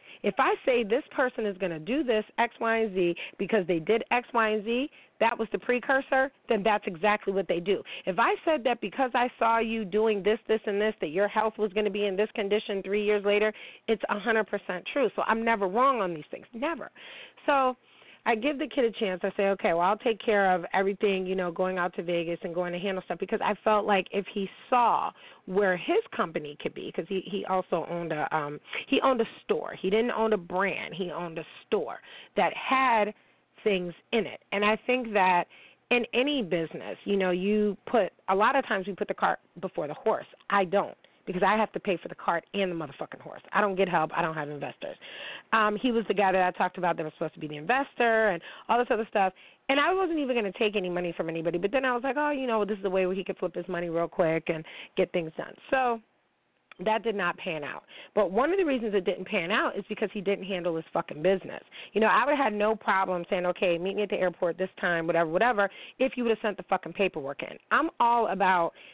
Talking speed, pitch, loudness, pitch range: 250 wpm, 205 Hz, -28 LUFS, 185-230 Hz